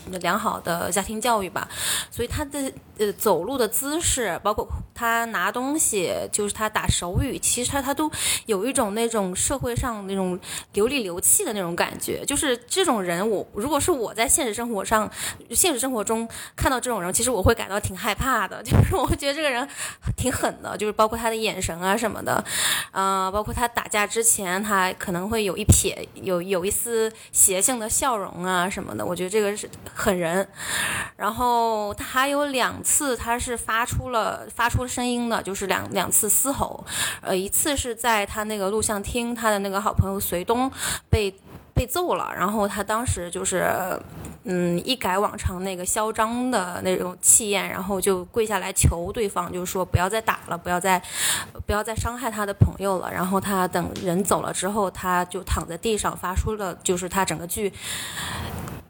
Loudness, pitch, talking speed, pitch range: -23 LUFS, 210 Hz, 275 characters per minute, 190-235 Hz